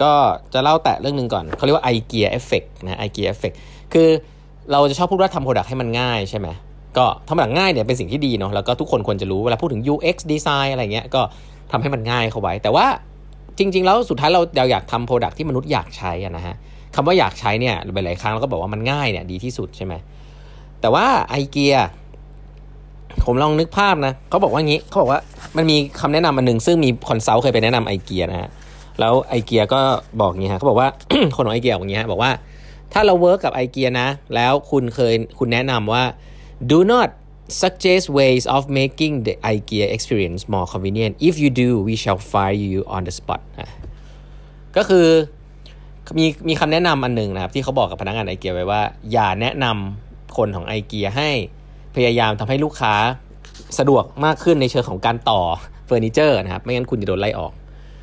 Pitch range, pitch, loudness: 110-150 Hz, 130 Hz, -18 LUFS